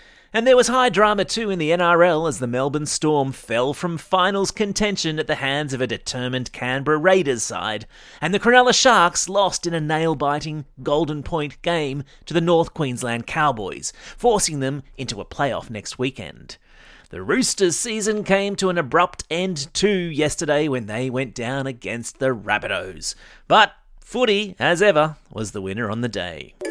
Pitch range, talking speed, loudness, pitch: 130-185 Hz, 170 wpm, -20 LUFS, 155 Hz